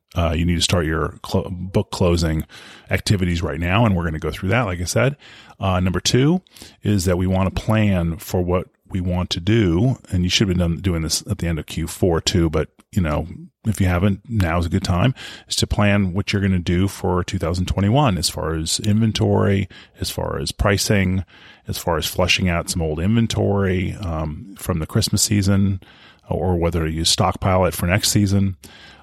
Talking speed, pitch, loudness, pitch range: 205 wpm, 95 Hz, -20 LUFS, 85-105 Hz